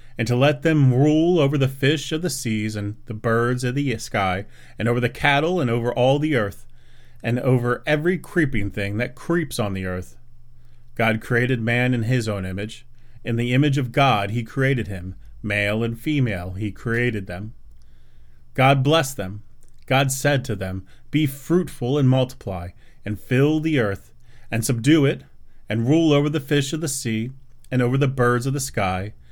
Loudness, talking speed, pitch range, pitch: -21 LUFS, 185 wpm, 105-140 Hz, 120 Hz